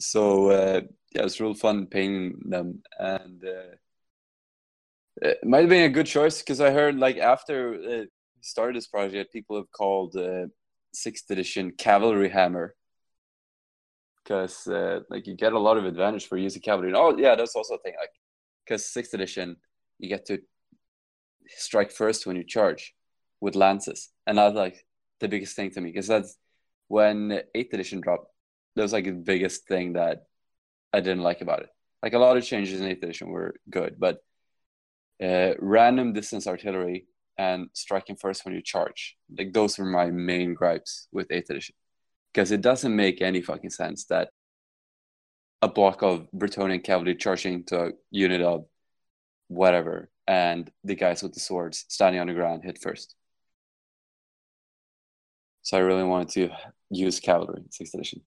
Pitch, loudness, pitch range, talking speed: 95 Hz, -25 LUFS, 90-105 Hz, 170 wpm